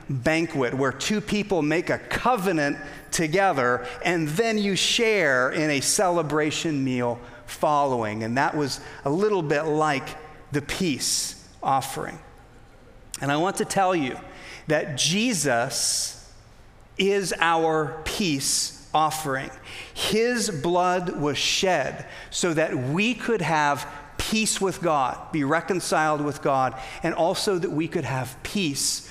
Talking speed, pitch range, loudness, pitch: 130 wpm, 130-180 Hz, -24 LUFS, 155 Hz